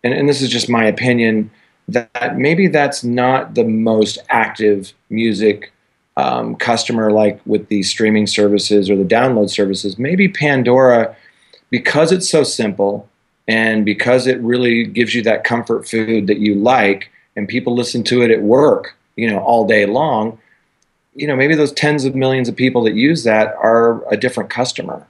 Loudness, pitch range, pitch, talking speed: -14 LUFS, 105-125 Hz, 115 Hz, 170 wpm